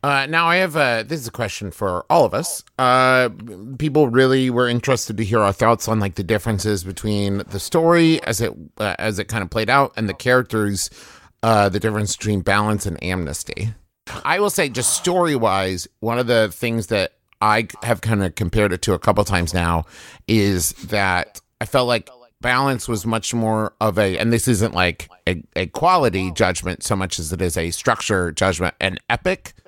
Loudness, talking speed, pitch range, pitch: -19 LUFS, 200 wpm, 95-120 Hz, 110 Hz